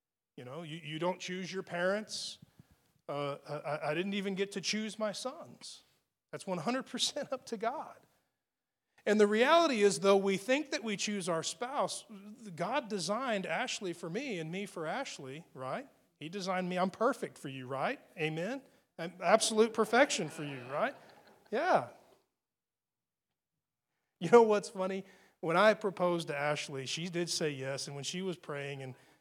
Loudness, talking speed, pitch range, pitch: -33 LUFS, 165 wpm, 160-215 Hz, 190 Hz